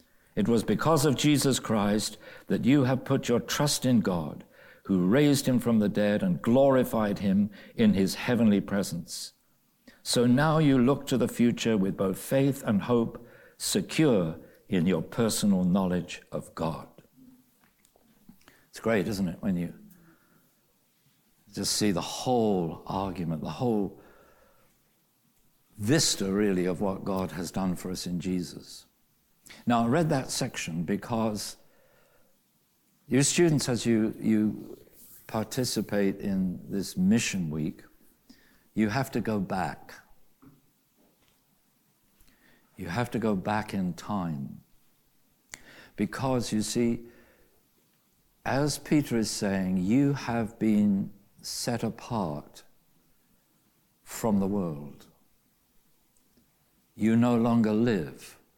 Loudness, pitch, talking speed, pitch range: -27 LUFS, 115 Hz, 120 wpm, 100-140 Hz